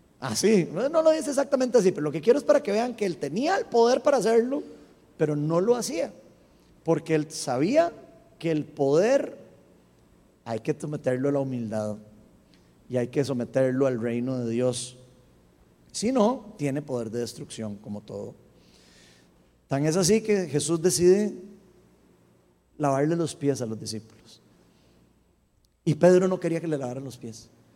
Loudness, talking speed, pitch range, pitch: -25 LUFS, 160 wpm, 115-190 Hz, 145 Hz